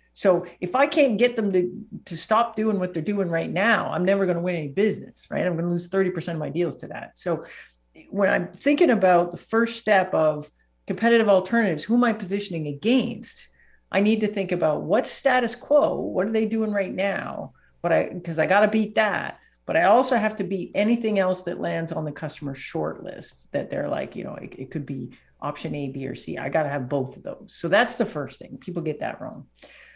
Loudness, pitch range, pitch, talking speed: -24 LUFS, 165-220 Hz, 190 Hz, 230 wpm